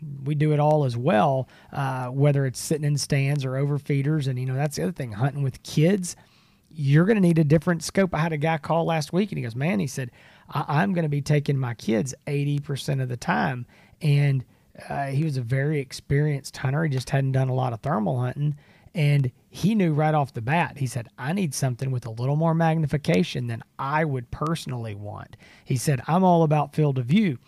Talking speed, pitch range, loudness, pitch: 225 wpm, 130-160 Hz, -24 LUFS, 145 Hz